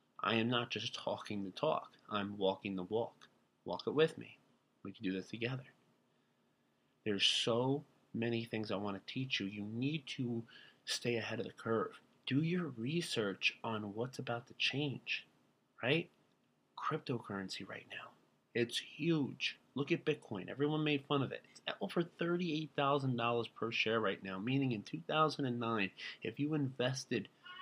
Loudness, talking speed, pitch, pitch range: -38 LUFS, 160 wpm, 120 Hz, 105-145 Hz